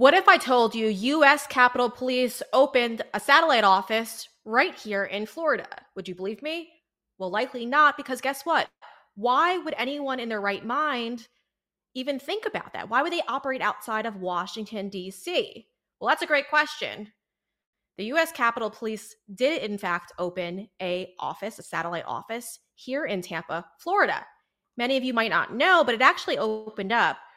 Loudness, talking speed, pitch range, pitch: -25 LUFS, 170 wpm, 205-280 Hz, 235 Hz